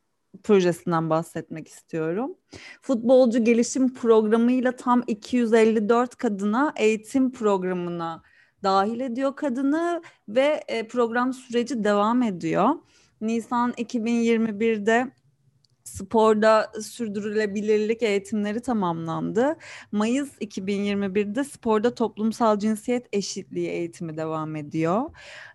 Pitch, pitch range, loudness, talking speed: 220 Hz, 200-245 Hz, -24 LUFS, 80 wpm